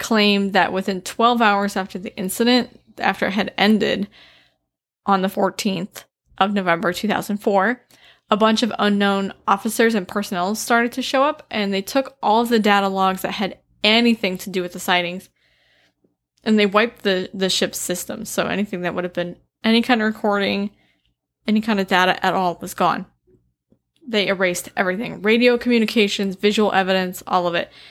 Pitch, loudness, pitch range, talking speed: 200 Hz, -19 LUFS, 190-220 Hz, 170 wpm